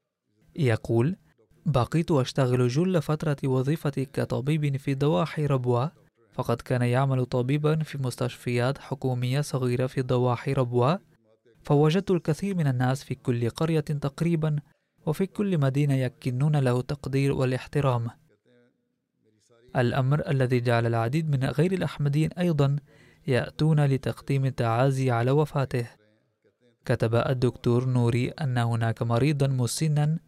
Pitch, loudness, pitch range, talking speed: 135 Hz, -26 LUFS, 125-150 Hz, 110 wpm